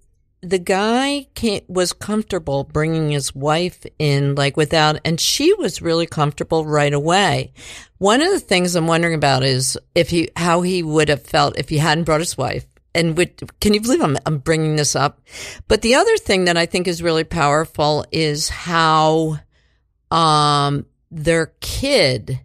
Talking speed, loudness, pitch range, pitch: 170 wpm, -17 LUFS, 145-180 Hz, 160 Hz